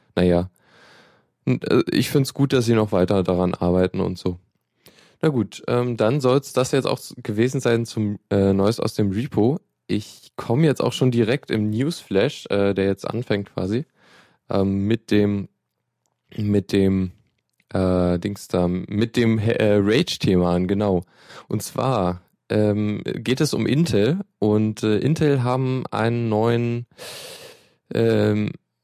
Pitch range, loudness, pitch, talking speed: 100-125 Hz, -21 LUFS, 110 Hz, 145 wpm